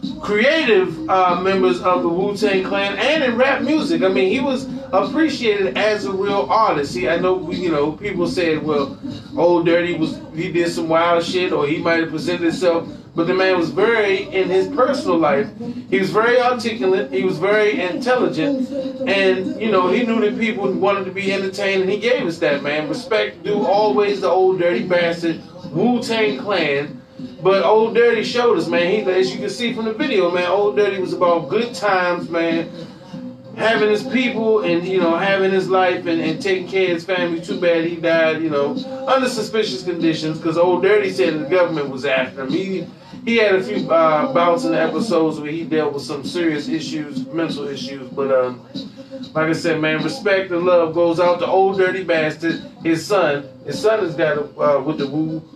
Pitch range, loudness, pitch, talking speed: 165-215 Hz, -18 LUFS, 185 Hz, 200 wpm